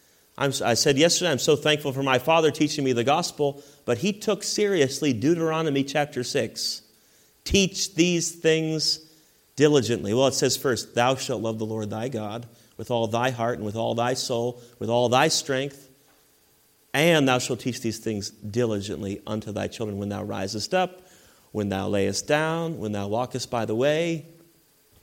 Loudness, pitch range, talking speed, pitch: -24 LUFS, 115-155 Hz, 175 wpm, 130 Hz